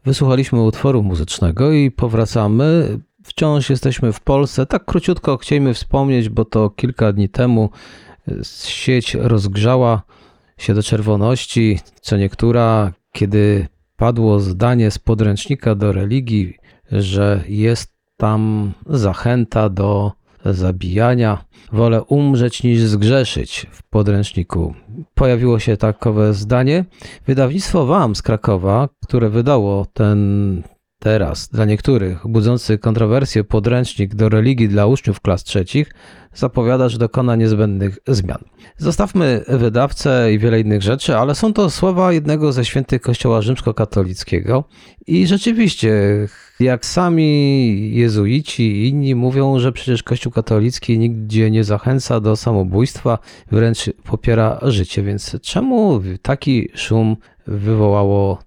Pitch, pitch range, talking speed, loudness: 115 Hz, 105-130 Hz, 115 wpm, -16 LUFS